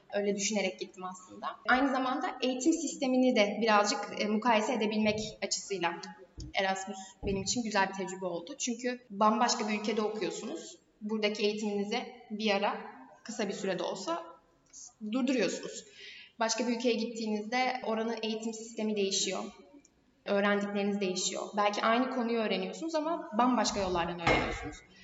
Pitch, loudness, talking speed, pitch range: 215 Hz, -32 LUFS, 125 wpm, 195-240 Hz